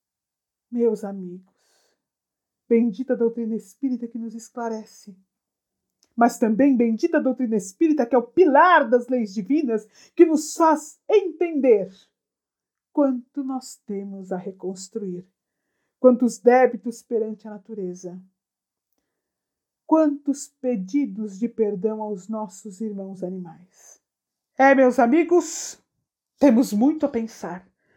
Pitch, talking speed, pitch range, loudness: 235 Hz, 110 wpm, 210-275 Hz, -21 LUFS